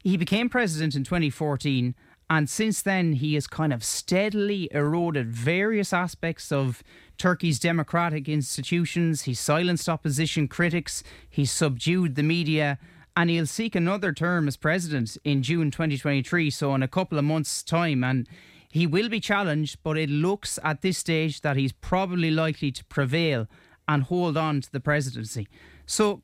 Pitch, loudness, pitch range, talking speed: 155 Hz, -25 LUFS, 145-175 Hz, 160 wpm